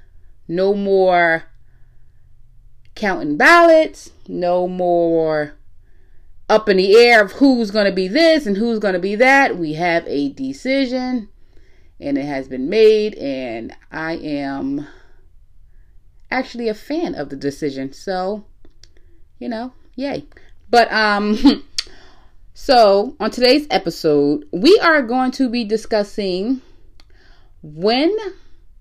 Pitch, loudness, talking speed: 205 Hz, -16 LUFS, 120 wpm